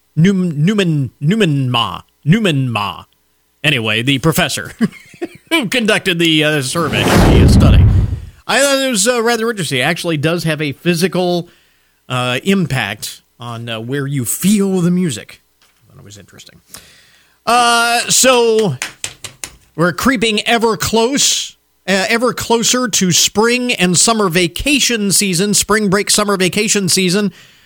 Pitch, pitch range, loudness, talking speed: 180 Hz, 145-220 Hz, -13 LUFS, 135 wpm